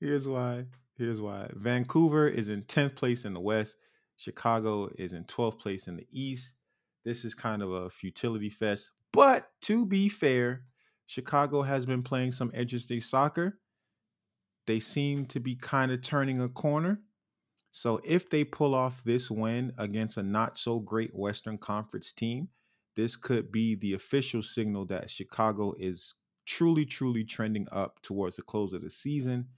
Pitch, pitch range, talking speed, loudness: 120 Hz, 105-135 Hz, 165 wpm, -31 LUFS